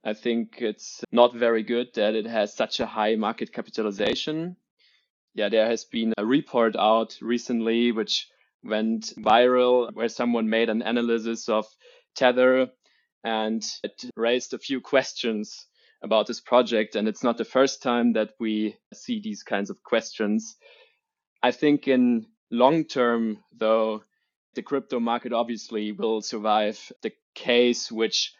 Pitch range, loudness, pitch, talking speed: 110-130 Hz, -25 LUFS, 120 Hz, 145 wpm